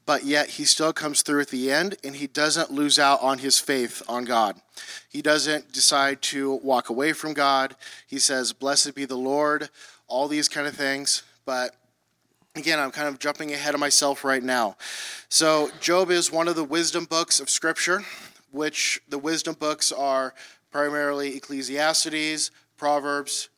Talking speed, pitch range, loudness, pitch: 170 wpm, 135-155 Hz, -23 LUFS, 145 Hz